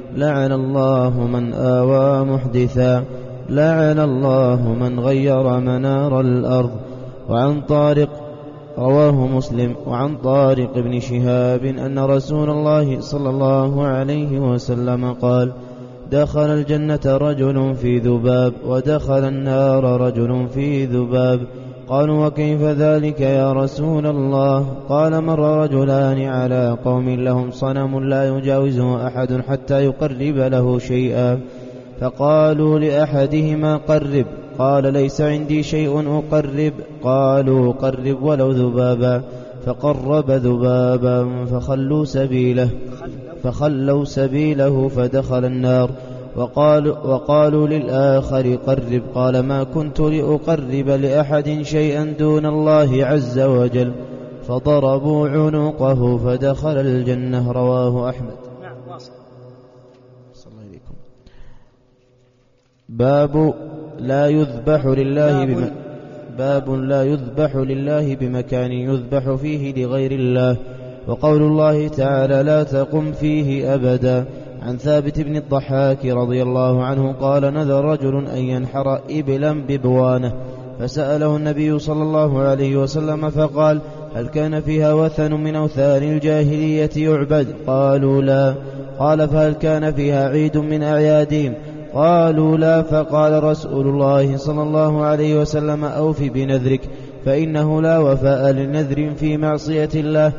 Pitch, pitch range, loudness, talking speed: 135 Hz, 125-150 Hz, -17 LUFS, 105 wpm